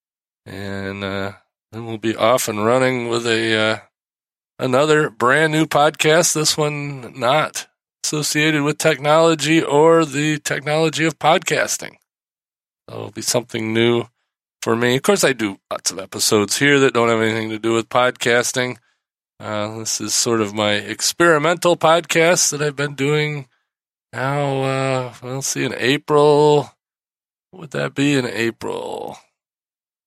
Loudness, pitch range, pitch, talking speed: -17 LUFS, 115-150 Hz, 130 Hz, 150 wpm